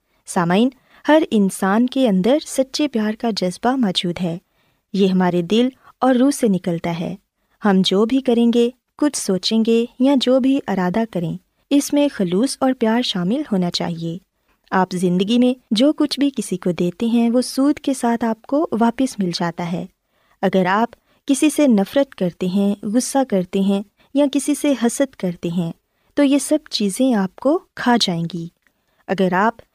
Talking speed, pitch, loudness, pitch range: 175 wpm, 225 Hz, -19 LUFS, 190-265 Hz